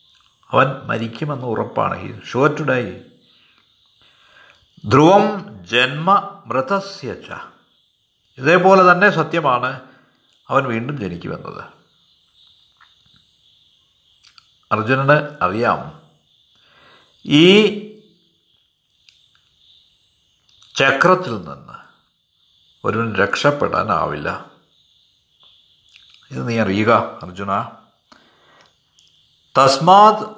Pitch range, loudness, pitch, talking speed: 120-190 Hz, -16 LUFS, 145 Hz, 55 wpm